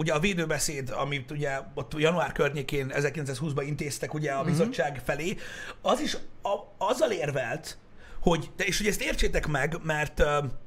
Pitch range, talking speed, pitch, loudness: 140-165 Hz, 145 wpm, 150 Hz, -29 LUFS